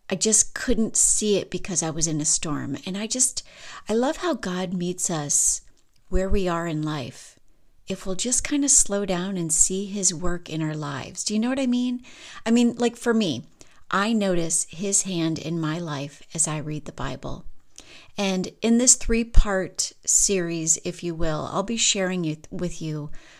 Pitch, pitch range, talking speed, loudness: 185 Hz, 160-215 Hz, 200 wpm, -23 LUFS